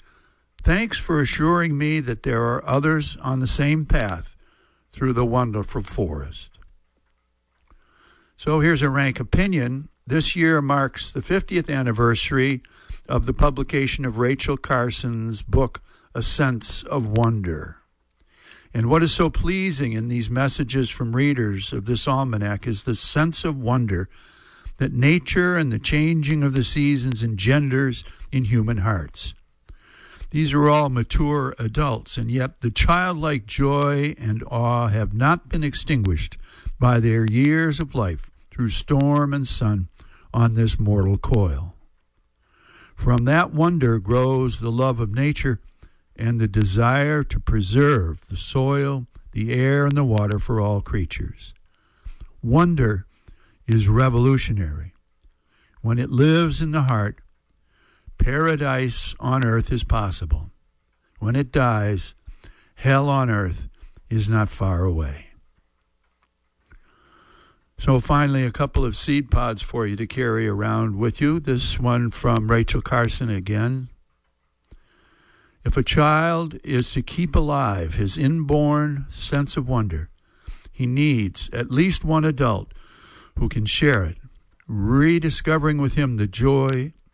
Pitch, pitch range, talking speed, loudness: 120 Hz, 105-140 Hz, 130 wpm, -21 LUFS